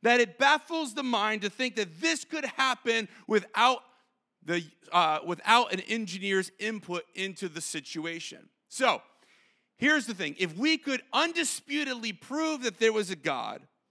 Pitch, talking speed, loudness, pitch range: 225 Hz, 150 wpm, -28 LUFS, 190-265 Hz